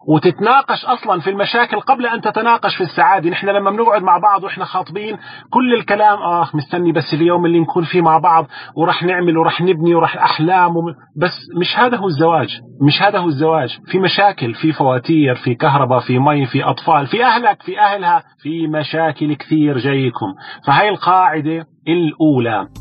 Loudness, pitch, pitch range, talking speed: -14 LUFS, 170 Hz, 155-200 Hz, 170 wpm